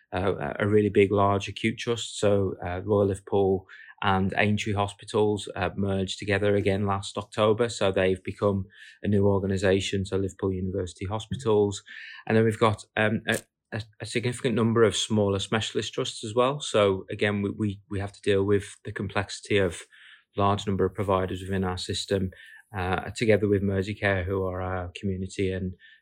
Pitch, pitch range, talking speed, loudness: 100 Hz, 95-105 Hz, 165 wpm, -26 LUFS